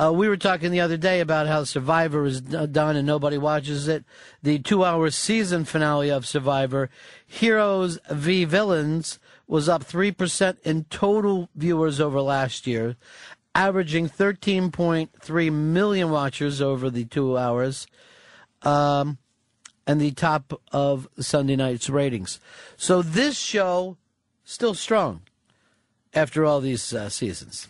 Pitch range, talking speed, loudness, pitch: 135-175 Hz, 130 wpm, -23 LUFS, 155 Hz